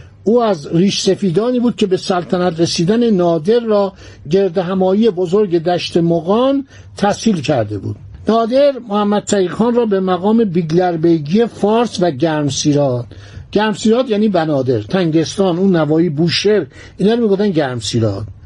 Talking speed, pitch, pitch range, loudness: 130 wpm, 185 Hz, 165-210 Hz, -15 LUFS